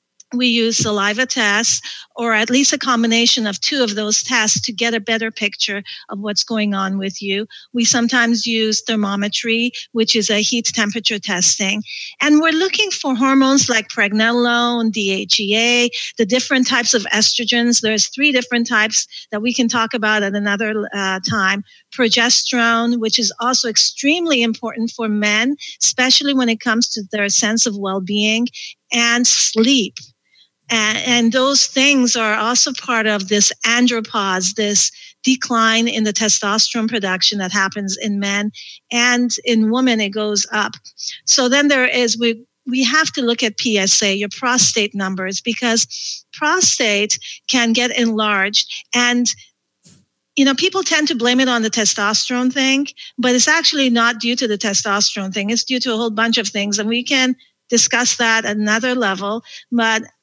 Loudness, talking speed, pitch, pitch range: -15 LUFS, 160 wpm, 230 Hz, 210-245 Hz